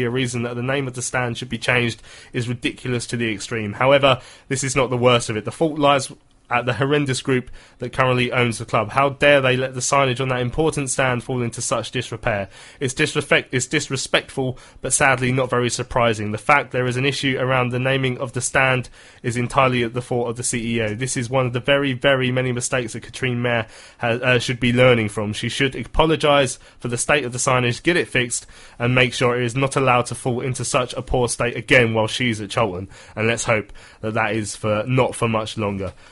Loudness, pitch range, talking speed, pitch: -20 LUFS, 120-135 Hz, 230 wpm, 125 Hz